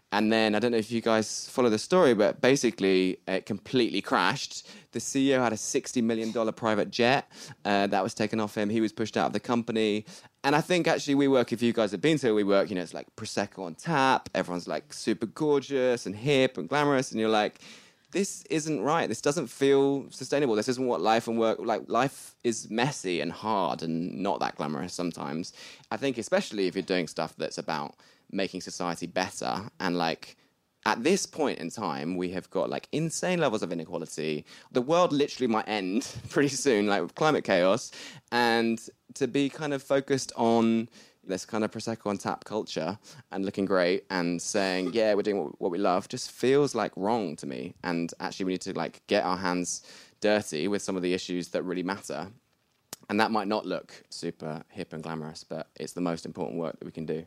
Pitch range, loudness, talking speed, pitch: 95-130 Hz, -28 LUFS, 210 wpm, 110 Hz